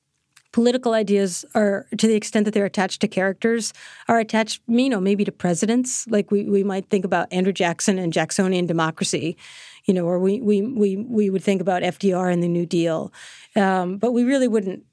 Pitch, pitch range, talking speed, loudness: 200 Hz, 185-220 Hz, 195 wpm, -21 LUFS